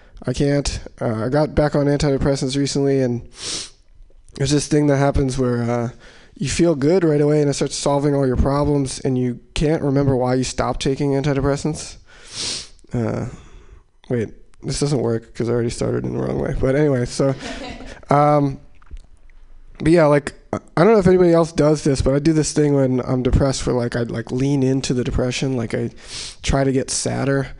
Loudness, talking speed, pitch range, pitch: -19 LUFS, 190 wpm, 125-145 Hz, 135 Hz